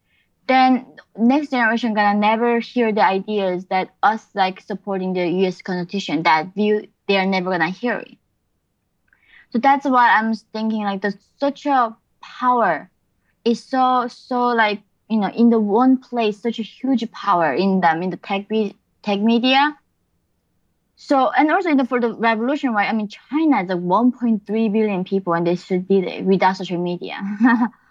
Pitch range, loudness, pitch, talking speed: 195-245 Hz, -19 LUFS, 220 Hz, 170 wpm